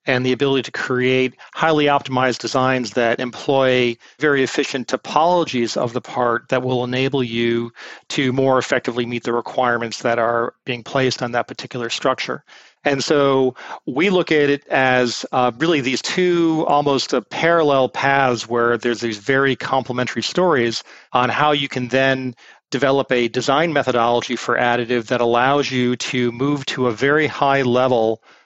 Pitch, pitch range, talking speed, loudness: 130 Hz, 120-140 Hz, 160 wpm, -18 LUFS